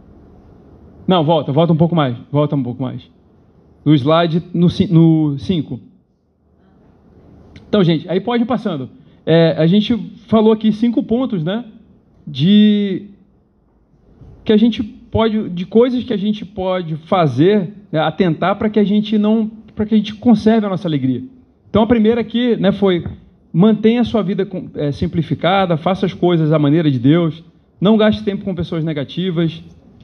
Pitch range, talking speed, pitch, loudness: 160-215 Hz, 165 wpm, 190 Hz, -16 LUFS